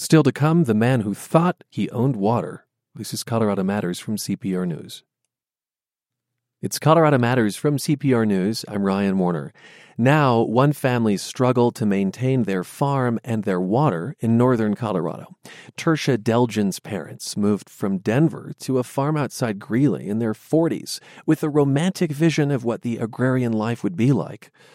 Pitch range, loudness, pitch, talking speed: 105-140 Hz, -21 LUFS, 120 Hz, 160 wpm